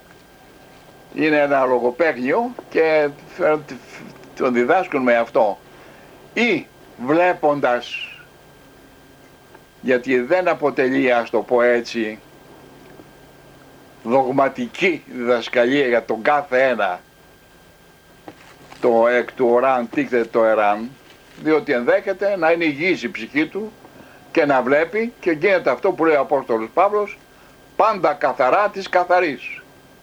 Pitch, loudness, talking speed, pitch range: 135 Hz, -19 LUFS, 110 wpm, 120-170 Hz